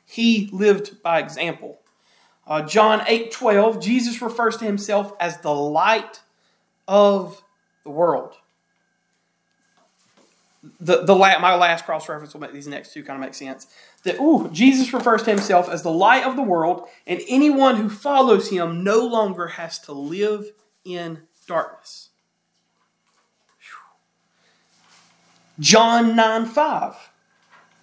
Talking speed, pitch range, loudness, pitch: 135 wpm, 170-225 Hz, -19 LUFS, 200 Hz